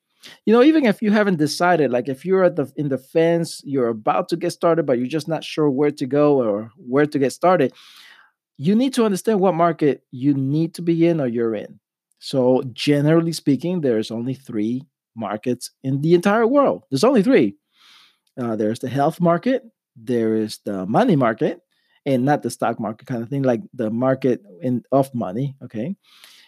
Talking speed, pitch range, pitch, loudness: 195 wpm, 125-170 Hz, 145 Hz, -20 LUFS